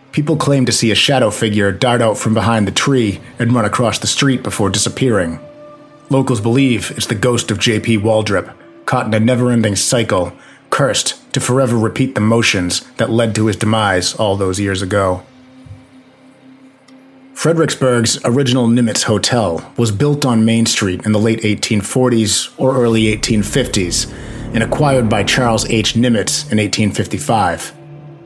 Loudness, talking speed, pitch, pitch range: -14 LUFS, 155 wpm, 115 Hz, 110-130 Hz